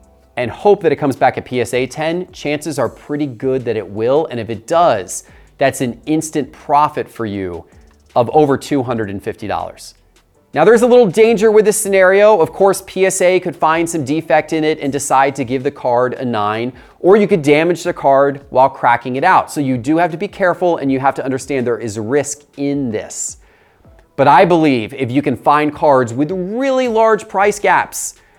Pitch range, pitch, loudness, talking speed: 130-180 Hz, 145 Hz, -15 LUFS, 200 wpm